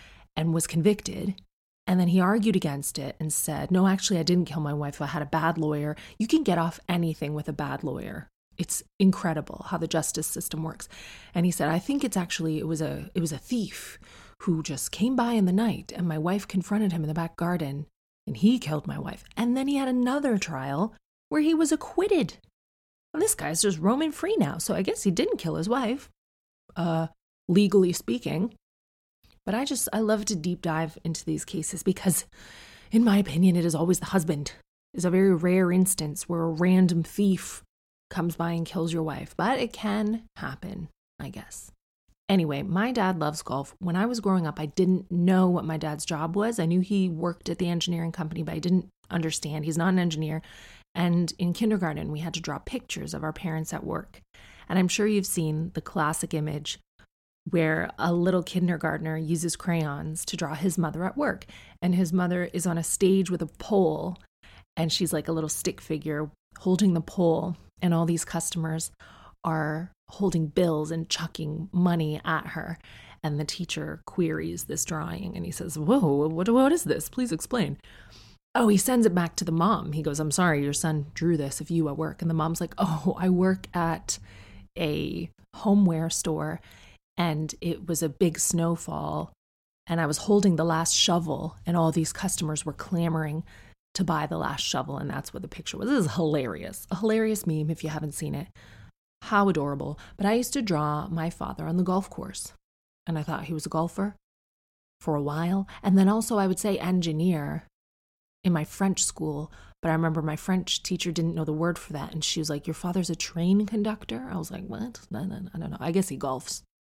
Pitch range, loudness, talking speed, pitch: 155-190 Hz, -27 LUFS, 205 wpm, 170 Hz